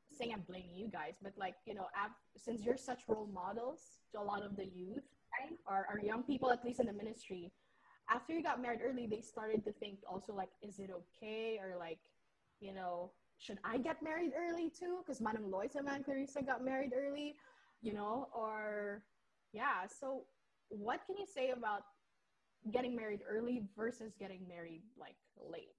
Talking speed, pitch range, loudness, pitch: 190 wpm, 200-260 Hz, -43 LUFS, 220 Hz